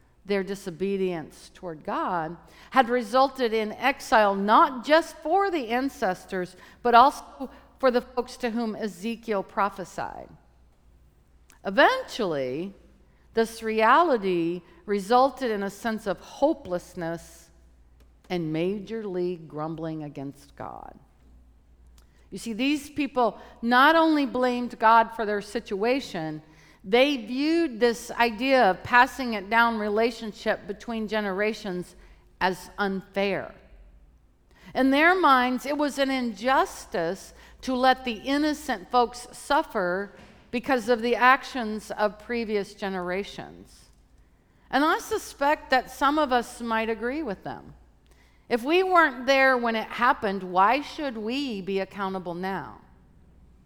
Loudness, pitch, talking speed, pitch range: -25 LUFS, 225 Hz, 115 wpm, 185-255 Hz